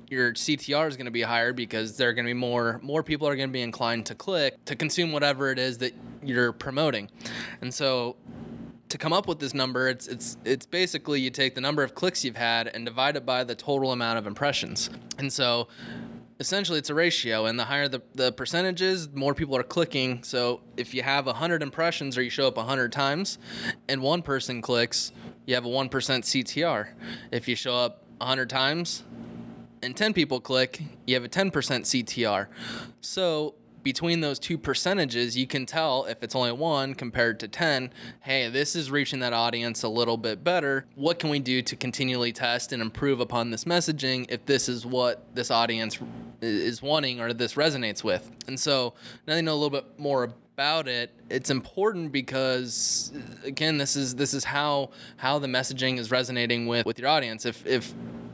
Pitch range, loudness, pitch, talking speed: 120-145 Hz, -27 LUFS, 130 Hz, 195 wpm